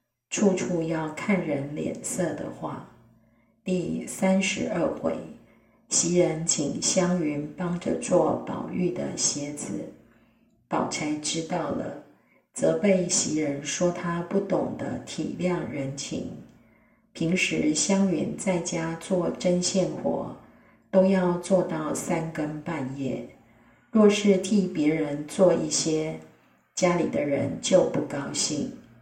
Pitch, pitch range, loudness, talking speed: 170 Hz, 150-185 Hz, -26 LUFS, 165 characters per minute